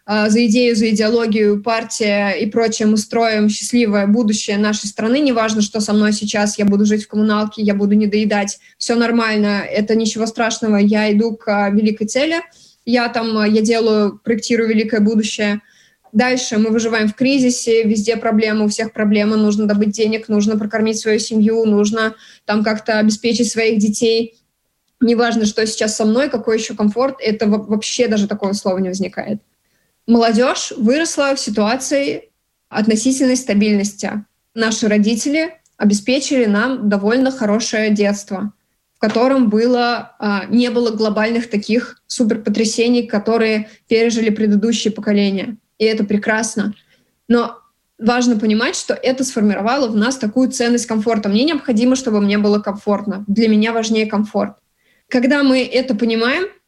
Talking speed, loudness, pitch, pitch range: 145 wpm, -16 LUFS, 220 Hz, 210-235 Hz